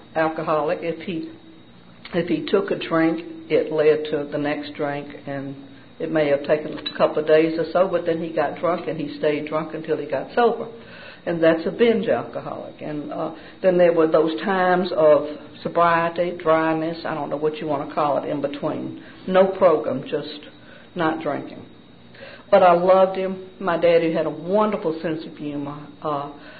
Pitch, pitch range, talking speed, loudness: 160 Hz, 150-170 Hz, 185 wpm, -21 LUFS